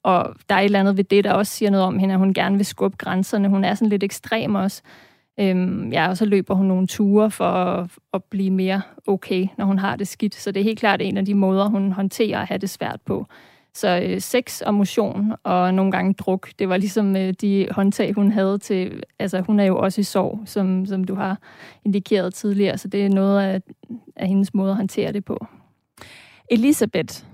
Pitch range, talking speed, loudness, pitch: 190-205 Hz, 230 wpm, -21 LUFS, 195 Hz